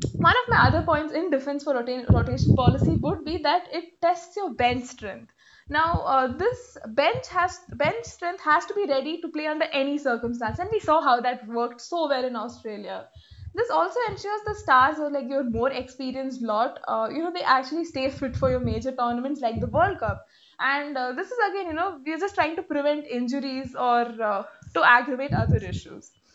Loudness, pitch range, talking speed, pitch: -25 LUFS, 255-345 Hz, 205 wpm, 285 Hz